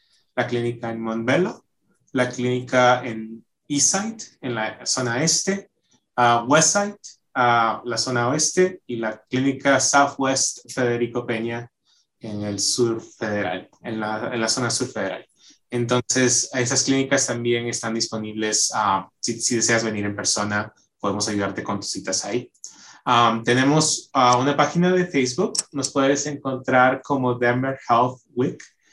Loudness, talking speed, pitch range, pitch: -21 LUFS, 140 wpm, 115-135 Hz, 125 Hz